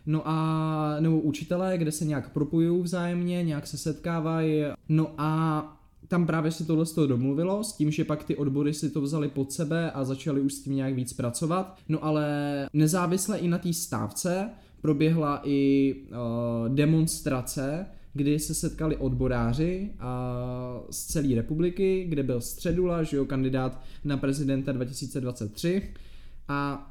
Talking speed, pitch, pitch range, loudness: 150 wpm, 150 Hz, 135-165 Hz, -28 LUFS